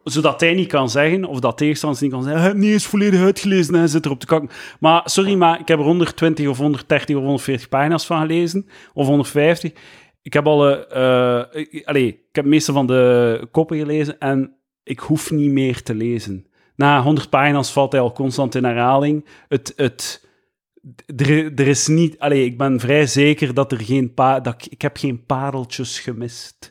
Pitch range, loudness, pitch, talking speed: 135-160 Hz, -17 LUFS, 145 Hz, 175 wpm